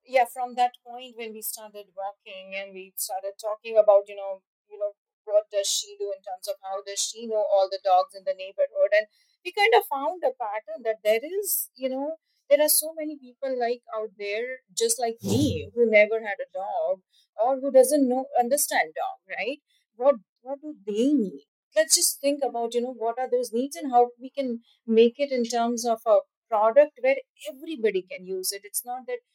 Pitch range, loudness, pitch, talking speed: 215-295 Hz, -25 LUFS, 250 Hz, 210 wpm